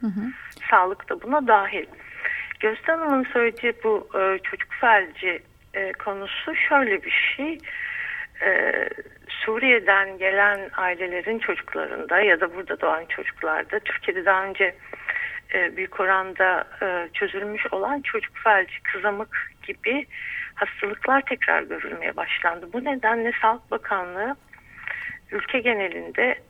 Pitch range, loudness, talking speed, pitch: 200-325 Hz, -23 LUFS, 100 wpm, 235 Hz